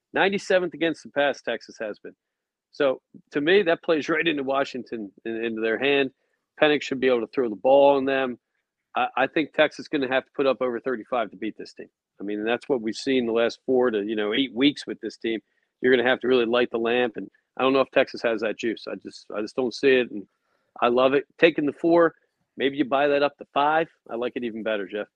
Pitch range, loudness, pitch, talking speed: 115-145 Hz, -24 LUFS, 130 Hz, 260 wpm